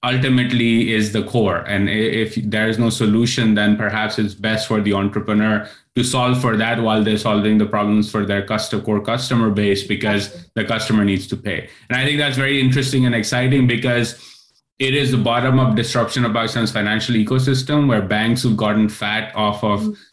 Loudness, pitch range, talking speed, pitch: -18 LUFS, 105-125 Hz, 185 wpm, 110 Hz